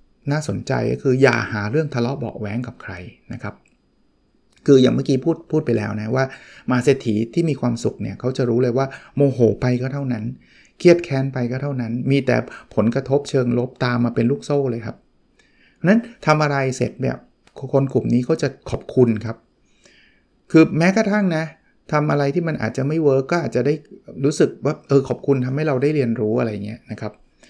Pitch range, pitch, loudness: 120-145 Hz, 130 Hz, -20 LUFS